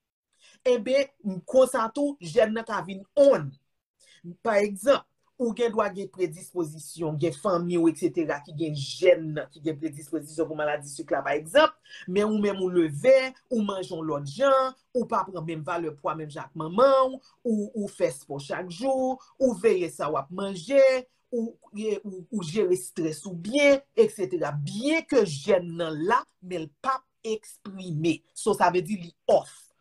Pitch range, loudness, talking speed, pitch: 165-255 Hz, -26 LUFS, 165 wpm, 195 Hz